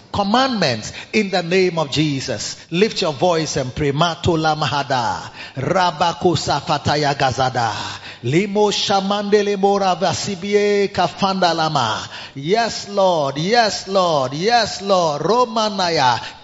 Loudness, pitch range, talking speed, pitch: -18 LUFS, 145-200 Hz, 100 wpm, 180 Hz